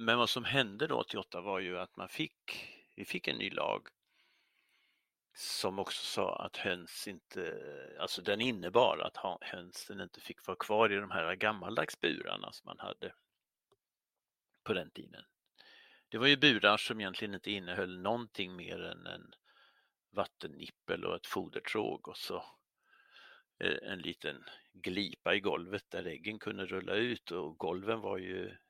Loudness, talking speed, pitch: -36 LUFS, 155 wpm, 120 Hz